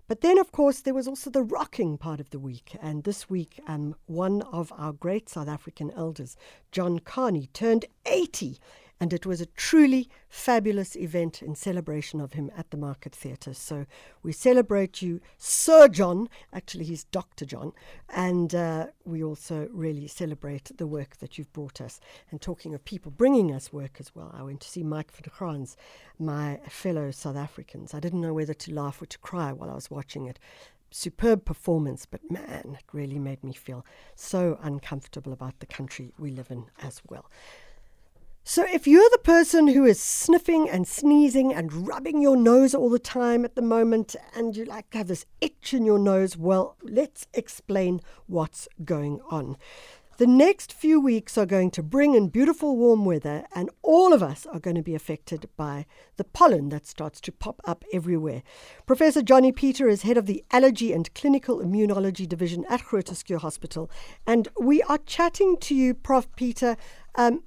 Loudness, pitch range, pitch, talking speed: -24 LUFS, 150-240 Hz, 180 Hz, 185 wpm